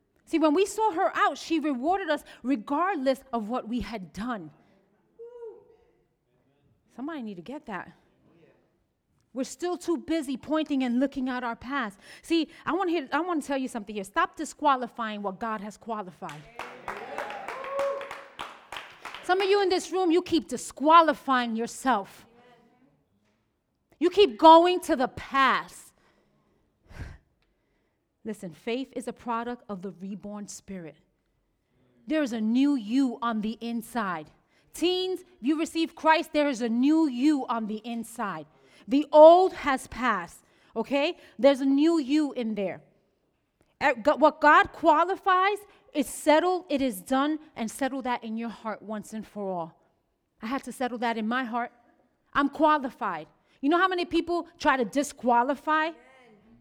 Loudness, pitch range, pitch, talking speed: -26 LUFS, 230-320 Hz, 270 Hz, 140 wpm